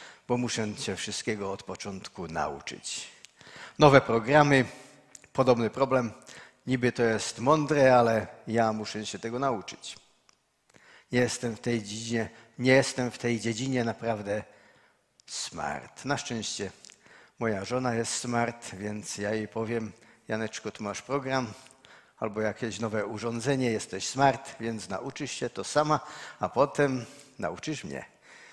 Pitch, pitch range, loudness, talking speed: 120 Hz, 110-130 Hz, -29 LUFS, 130 wpm